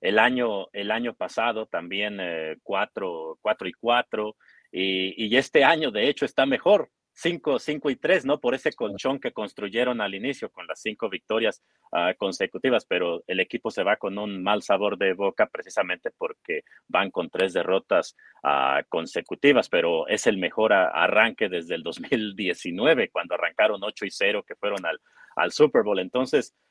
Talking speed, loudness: 170 wpm, -25 LUFS